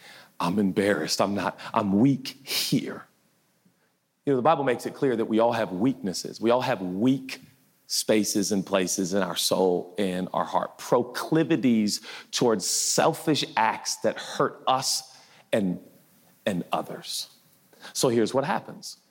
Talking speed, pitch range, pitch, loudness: 145 wpm, 100-130 Hz, 115 Hz, -26 LUFS